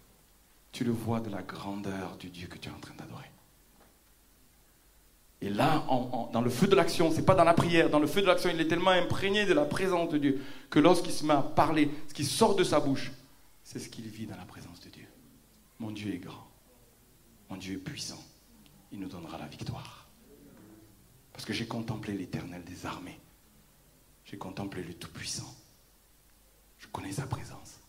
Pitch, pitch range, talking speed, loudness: 125 Hz, 105-150 Hz, 200 wpm, -29 LUFS